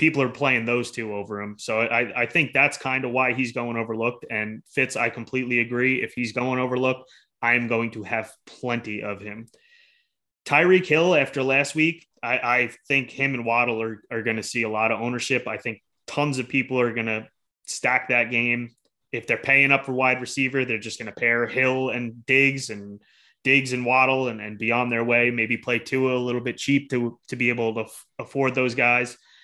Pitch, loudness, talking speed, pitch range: 120 Hz, -23 LUFS, 215 wpm, 115-130 Hz